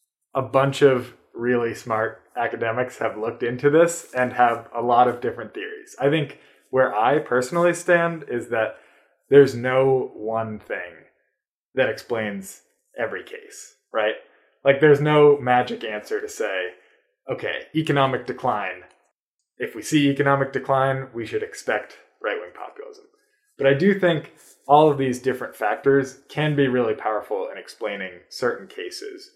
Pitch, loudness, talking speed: 145 Hz, -22 LUFS, 145 wpm